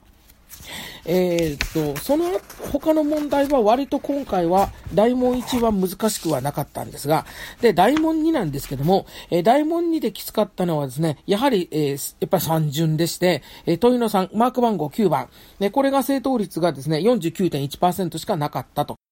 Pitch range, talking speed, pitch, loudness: 160-250 Hz, 310 characters per minute, 190 Hz, -21 LUFS